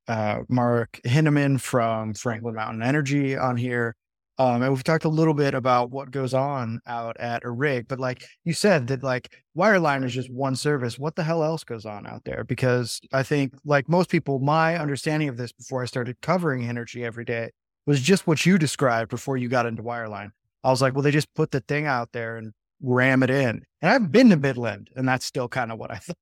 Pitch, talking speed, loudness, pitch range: 130 Hz, 225 wpm, -24 LUFS, 120-145 Hz